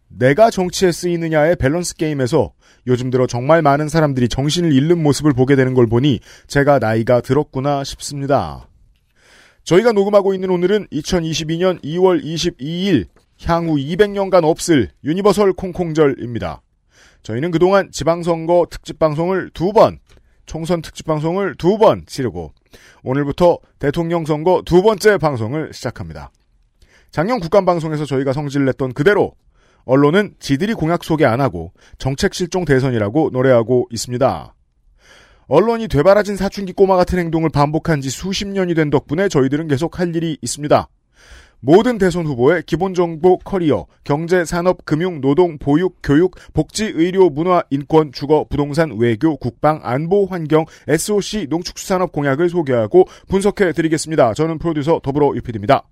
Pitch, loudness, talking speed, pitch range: 160 Hz, -16 LUFS, 335 characters per minute, 135-180 Hz